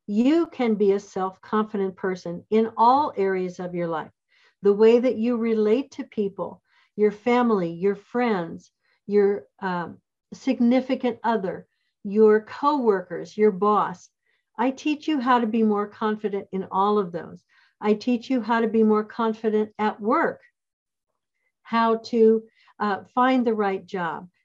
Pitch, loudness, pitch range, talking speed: 215 Hz, -23 LUFS, 200-245 Hz, 150 wpm